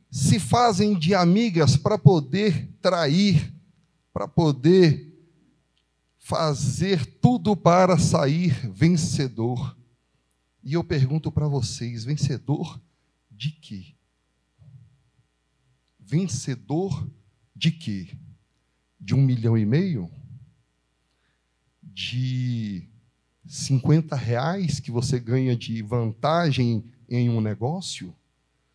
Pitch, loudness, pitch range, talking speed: 135 Hz, -23 LUFS, 115-160 Hz, 85 wpm